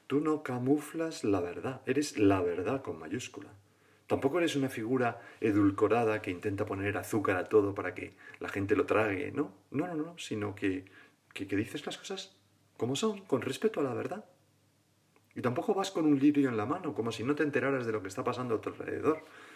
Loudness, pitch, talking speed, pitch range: -32 LUFS, 130 Hz, 205 wpm, 105-150 Hz